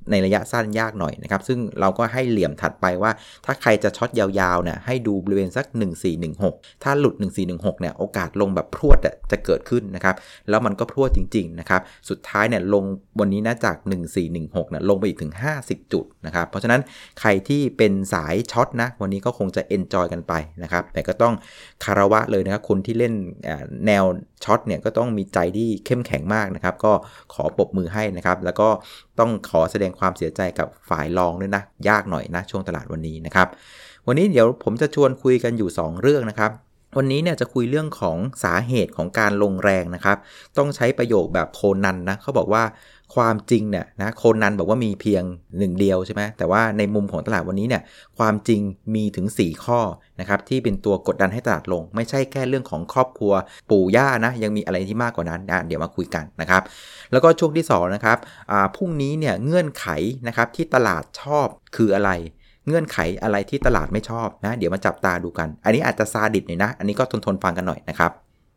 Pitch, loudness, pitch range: 105 Hz, -21 LUFS, 95-115 Hz